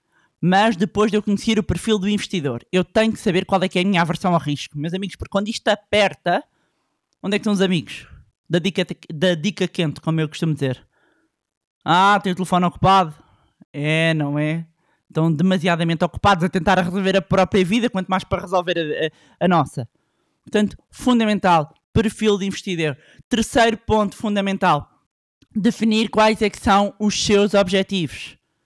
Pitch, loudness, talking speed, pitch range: 190 Hz, -19 LUFS, 175 wpm, 165-205 Hz